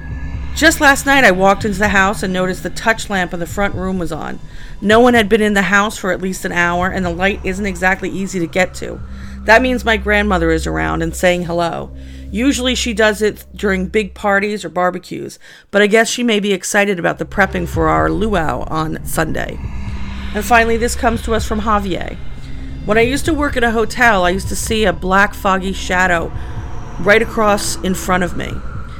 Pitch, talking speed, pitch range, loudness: 195 Hz, 215 wpm, 180-220 Hz, -15 LUFS